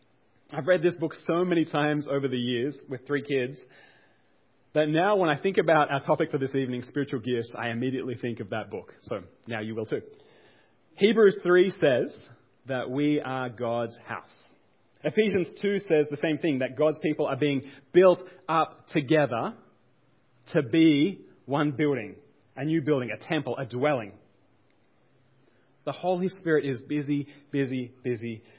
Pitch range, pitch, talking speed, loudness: 125-160 Hz, 145 Hz, 160 wpm, -27 LUFS